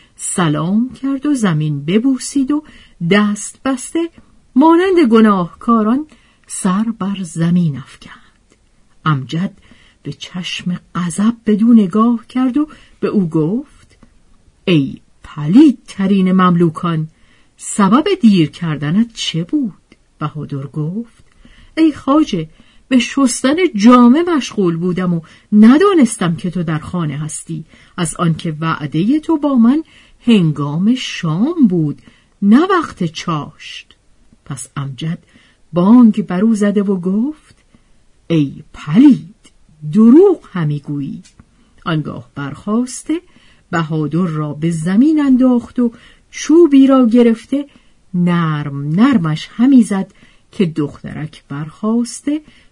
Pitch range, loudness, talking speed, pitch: 160-250 Hz, -14 LUFS, 105 wpm, 200 Hz